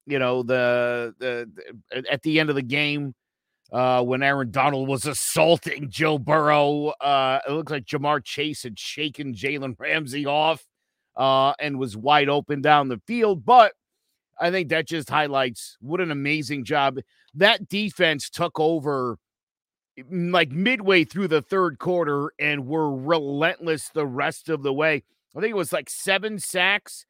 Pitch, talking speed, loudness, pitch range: 150 Hz, 160 wpm, -22 LUFS, 140-165 Hz